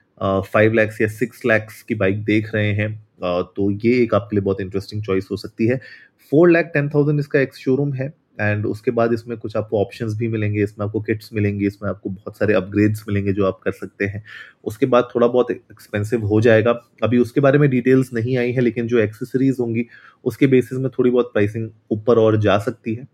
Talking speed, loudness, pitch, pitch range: 220 wpm, -19 LUFS, 110 Hz, 105-125 Hz